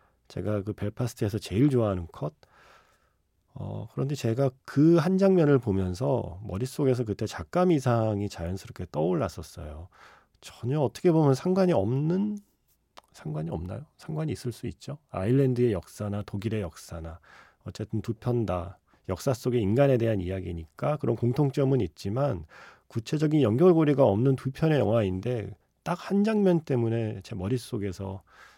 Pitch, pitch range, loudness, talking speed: 115 Hz, 100-140 Hz, -27 LUFS, 320 characters per minute